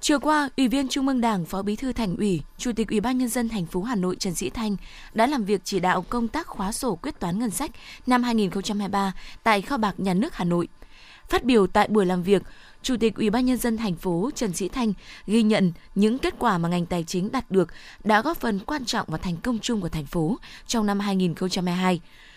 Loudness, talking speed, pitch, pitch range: -25 LUFS, 240 wpm, 210 Hz, 185-245 Hz